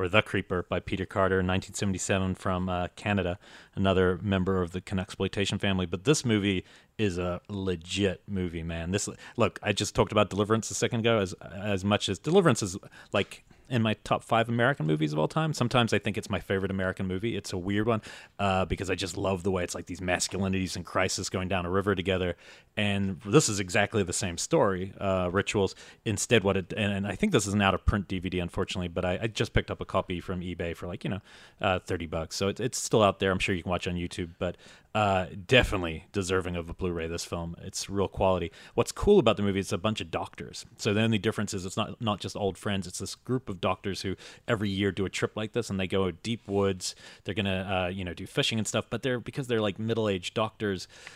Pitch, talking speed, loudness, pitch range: 95 Hz, 240 wpm, -29 LUFS, 90-105 Hz